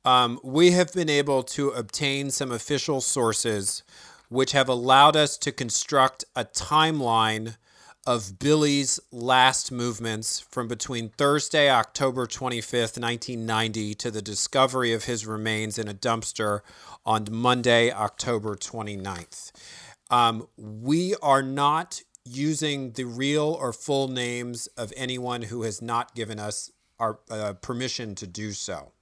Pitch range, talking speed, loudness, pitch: 110-135 Hz, 130 wpm, -25 LUFS, 120 Hz